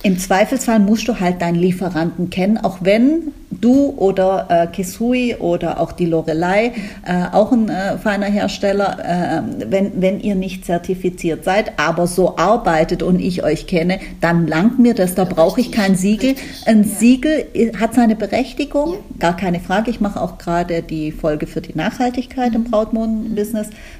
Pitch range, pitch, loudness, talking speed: 175-225 Hz, 195 Hz, -17 LUFS, 165 wpm